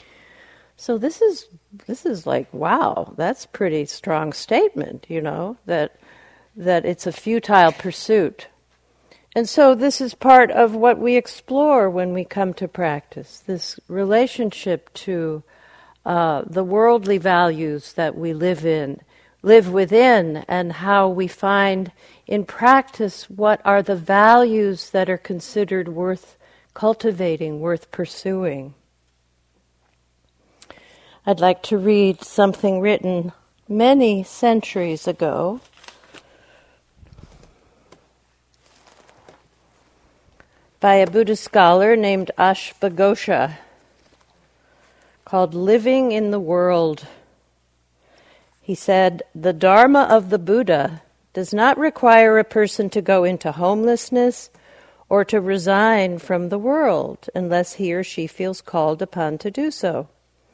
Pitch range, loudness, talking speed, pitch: 170-220 Hz, -18 LUFS, 115 wpm, 190 Hz